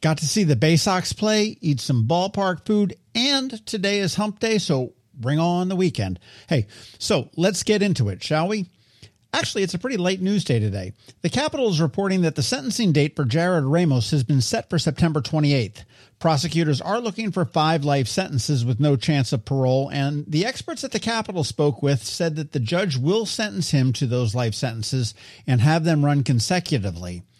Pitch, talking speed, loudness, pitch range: 155 Hz, 195 wpm, -22 LUFS, 130-190 Hz